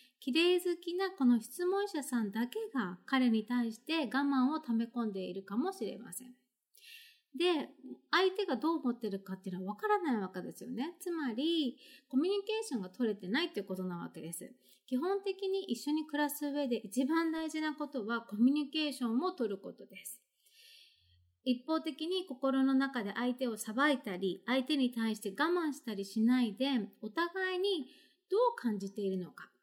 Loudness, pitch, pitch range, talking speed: -35 LUFS, 260 Hz, 225-320 Hz, 350 characters per minute